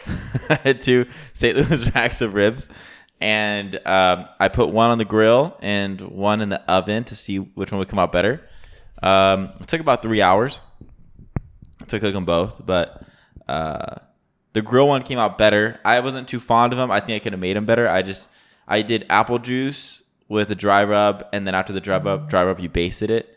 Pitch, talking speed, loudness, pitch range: 105 Hz, 210 wpm, -20 LUFS, 95-120 Hz